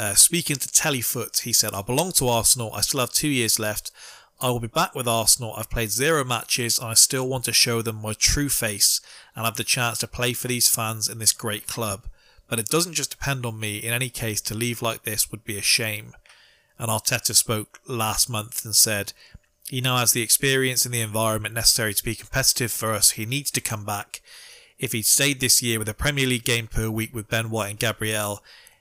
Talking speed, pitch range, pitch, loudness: 230 wpm, 110-125 Hz, 115 Hz, -21 LUFS